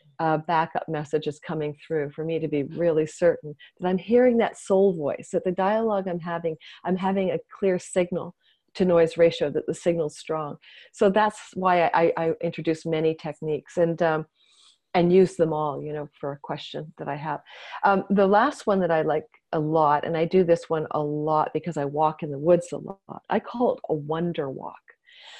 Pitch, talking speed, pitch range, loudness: 165 Hz, 215 wpm, 155-185 Hz, -25 LUFS